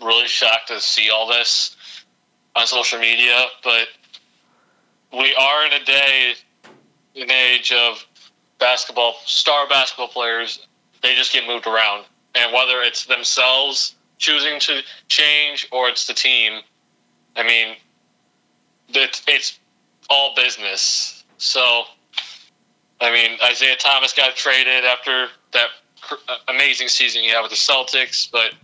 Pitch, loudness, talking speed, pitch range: 125 Hz, -16 LUFS, 130 wpm, 115-130 Hz